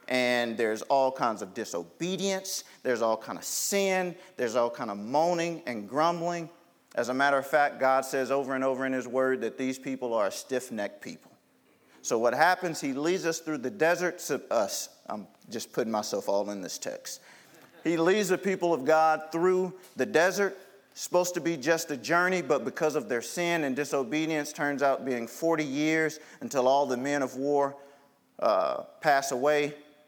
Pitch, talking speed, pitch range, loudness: 150 Hz, 185 wpm, 135-175 Hz, -28 LUFS